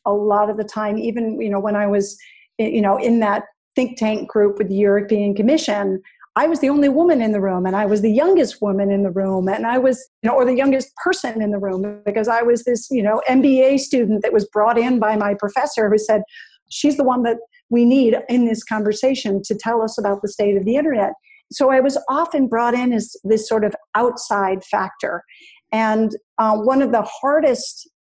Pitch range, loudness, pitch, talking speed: 210-260 Hz, -18 LUFS, 225 Hz, 225 wpm